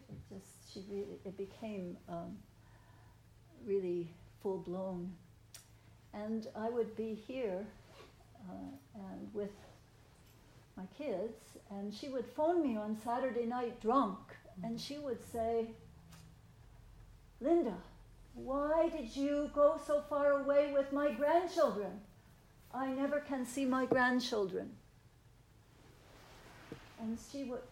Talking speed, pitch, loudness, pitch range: 115 wpm, 215 Hz, -37 LUFS, 165-270 Hz